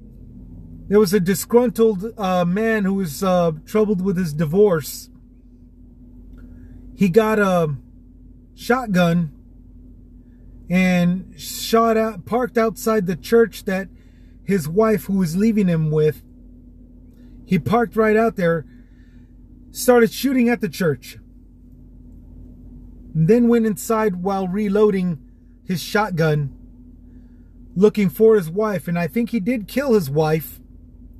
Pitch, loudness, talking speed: 175 Hz, -19 LUFS, 120 wpm